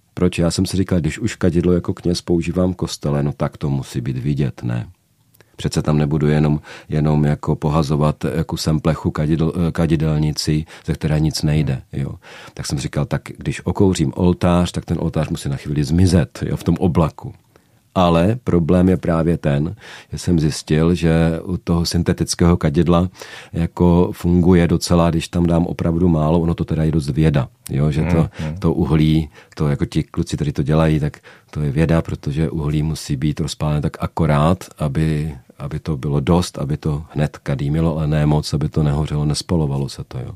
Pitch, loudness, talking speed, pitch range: 80 Hz, -19 LUFS, 185 wpm, 75-85 Hz